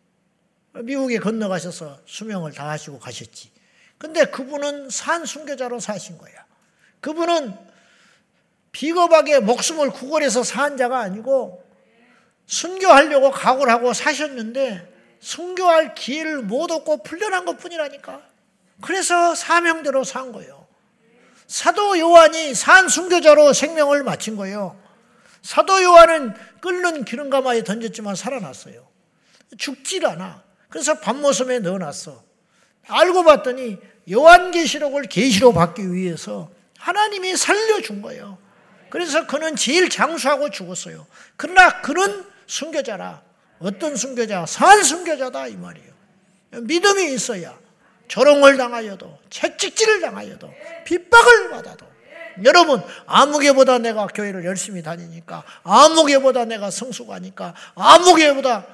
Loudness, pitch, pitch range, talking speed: -16 LUFS, 265 Hz, 205-320 Hz, 285 characters per minute